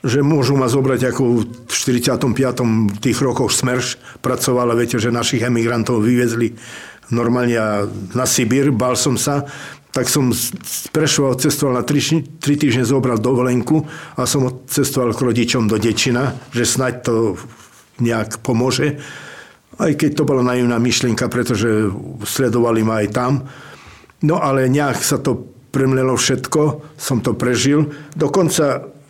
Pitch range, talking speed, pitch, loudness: 120-140 Hz, 135 wpm, 125 Hz, -17 LUFS